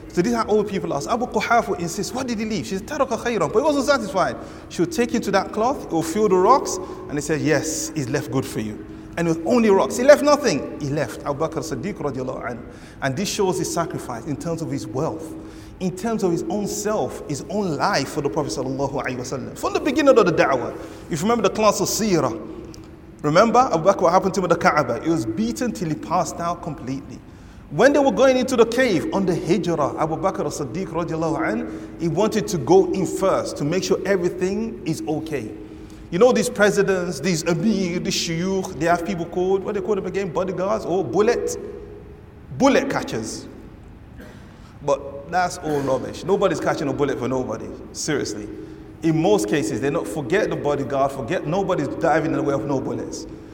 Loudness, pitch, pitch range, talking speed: -21 LUFS, 175 Hz, 145-210 Hz, 210 wpm